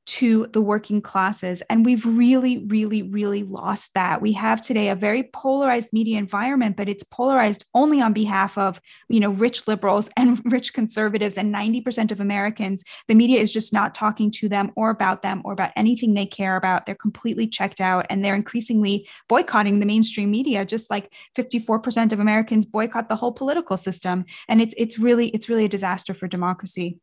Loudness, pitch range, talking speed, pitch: -21 LUFS, 200-230 Hz, 190 wpm, 215 Hz